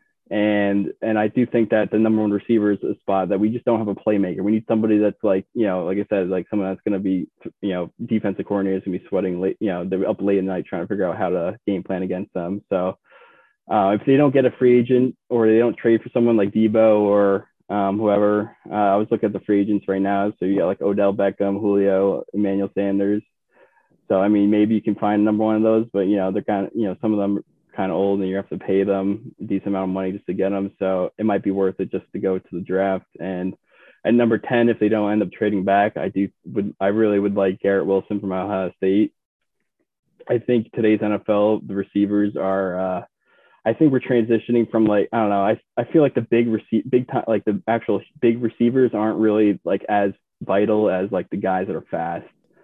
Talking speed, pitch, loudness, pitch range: 250 wpm, 105 Hz, -20 LUFS, 95-110 Hz